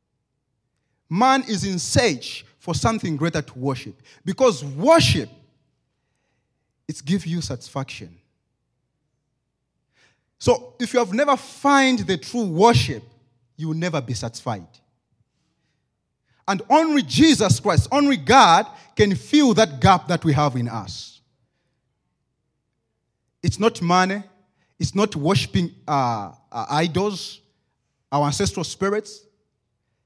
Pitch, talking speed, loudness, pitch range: 150 Hz, 110 wpm, -20 LUFS, 125-205 Hz